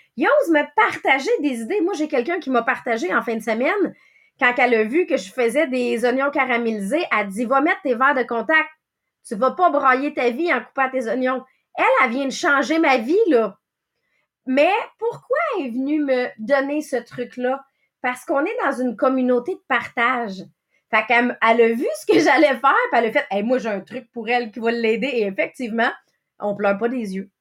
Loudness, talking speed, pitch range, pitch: -20 LUFS, 220 wpm, 235-290 Hz, 260 Hz